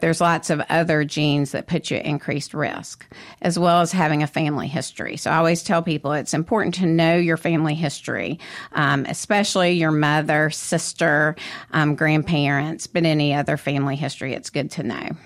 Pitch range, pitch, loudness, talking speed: 150-170 Hz, 155 Hz, -21 LUFS, 180 wpm